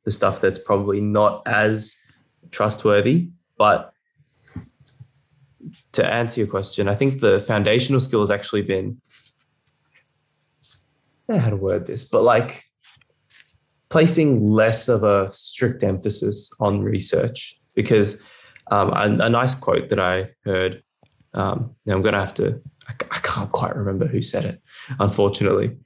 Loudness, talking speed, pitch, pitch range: -20 LUFS, 140 wpm, 110 Hz, 100-130 Hz